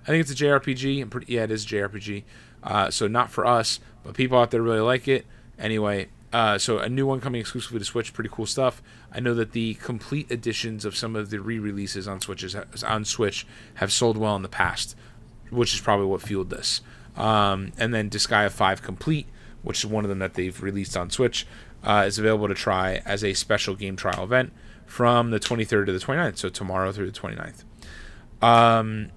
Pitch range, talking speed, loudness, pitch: 100-120 Hz, 210 wpm, -24 LUFS, 110 Hz